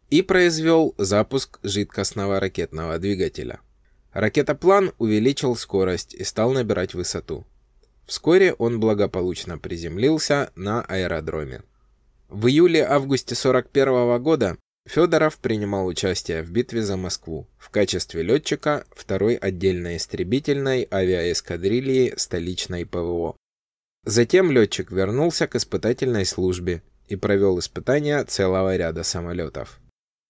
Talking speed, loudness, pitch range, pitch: 100 wpm, -21 LUFS, 90-130 Hz, 100 Hz